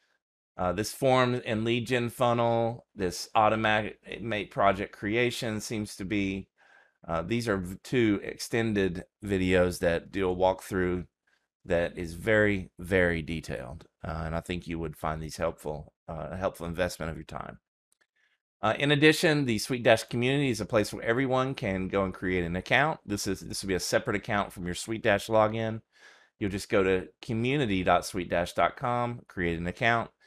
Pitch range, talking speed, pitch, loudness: 90-115 Hz, 165 wpm, 100 Hz, -28 LUFS